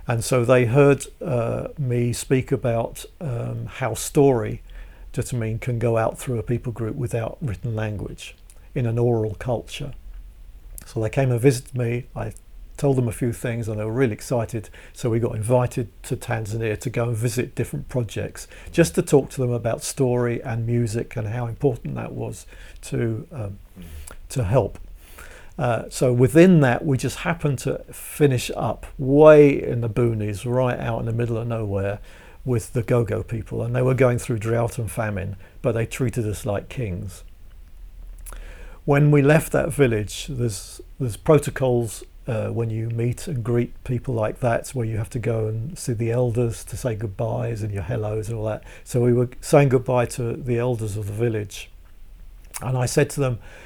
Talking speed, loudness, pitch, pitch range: 185 wpm, -22 LUFS, 120 Hz, 110-130 Hz